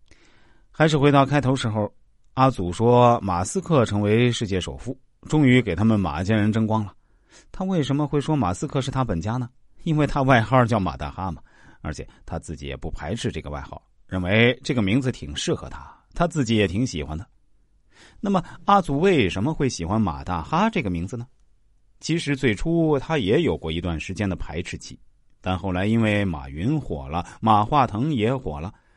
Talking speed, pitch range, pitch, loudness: 280 characters per minute, 95-135 Hz, 110 Hz, -22 LUFS